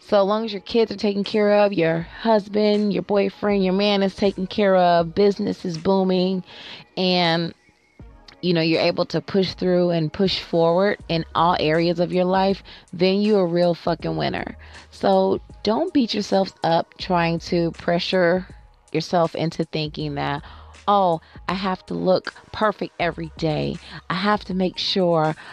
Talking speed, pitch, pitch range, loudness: 165 wpm, 180 Hz, 165-200 Hz, -21 LUFS